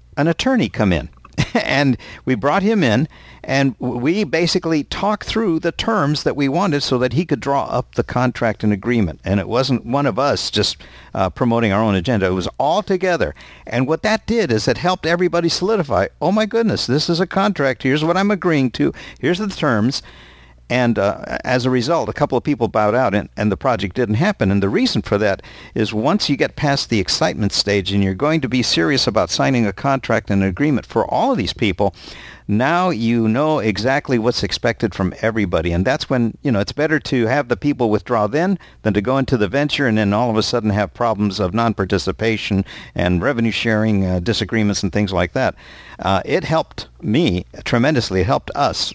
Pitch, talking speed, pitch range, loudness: 125 Hz, 210 wpm, 105-150 Hz, -18 LUFS